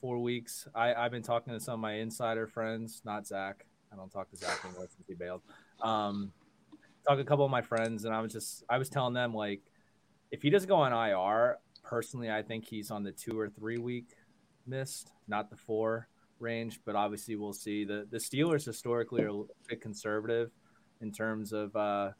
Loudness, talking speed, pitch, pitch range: -35 LUFS, 205 wpm, 110 Hz, 105-120 Hz